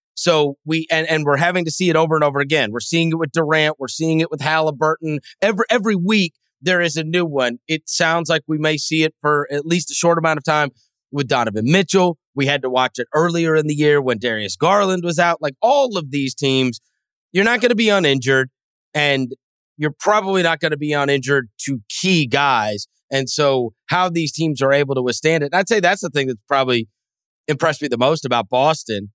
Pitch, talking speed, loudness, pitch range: 155 Hz, 225 wpm, -18 LUFS, 140-165 Hz